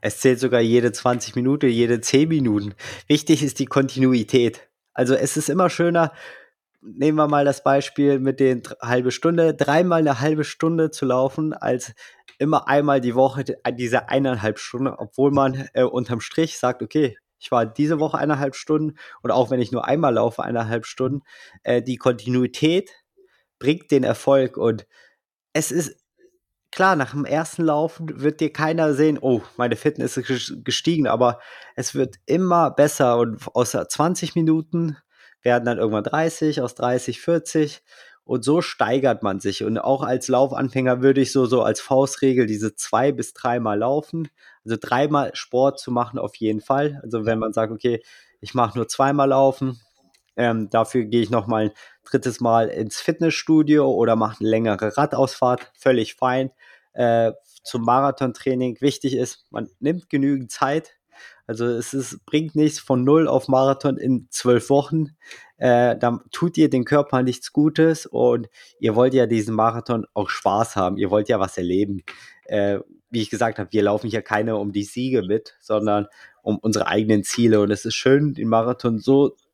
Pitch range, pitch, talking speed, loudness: 115-145 Hz, 130 Hz, 170 wpm, -21 LUFS